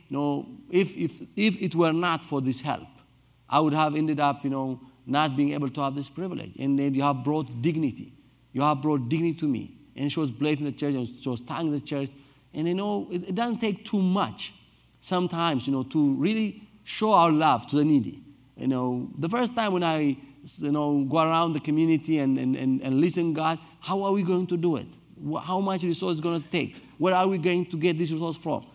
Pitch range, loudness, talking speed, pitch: 140-175 Hz, -26 LUFS, 240 wpm, 155 Hz